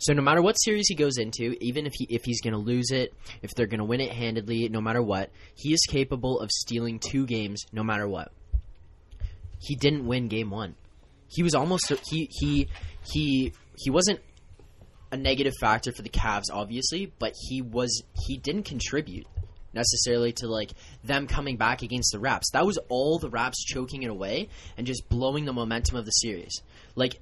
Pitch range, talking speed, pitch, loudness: 100-130 Hz, 190 wpm, 115 Hz, -27 LUFS